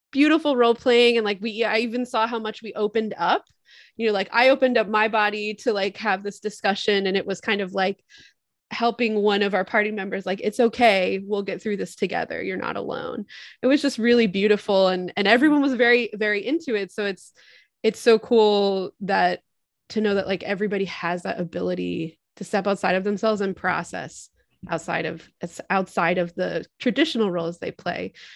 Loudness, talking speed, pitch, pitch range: -22 LUFS, 195 wpm, 210 Hz, 190-230 Hz